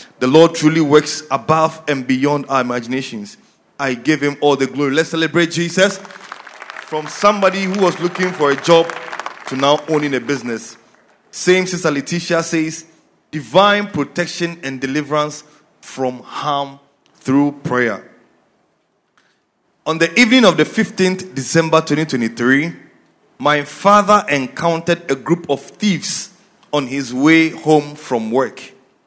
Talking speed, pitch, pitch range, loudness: 130 wpm, 155 Hz, 140-170 Hz, -16 LUFS